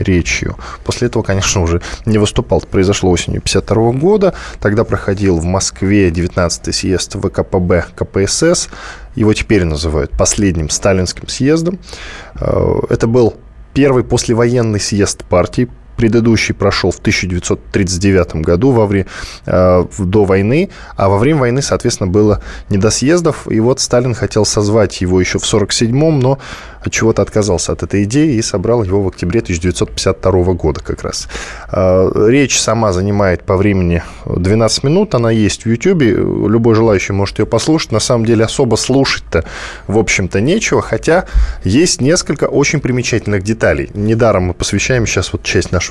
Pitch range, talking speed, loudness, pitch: 95-115 Hz, 150 wpm, -13 LUFS, 105 Hz